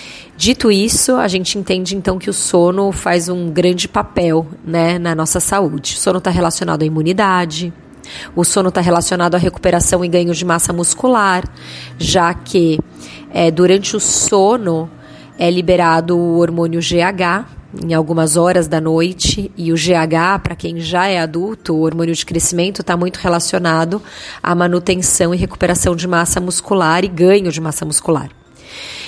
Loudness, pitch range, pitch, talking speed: -14 LUFS, 165-185 Hz, 175 Hz, 160 wpm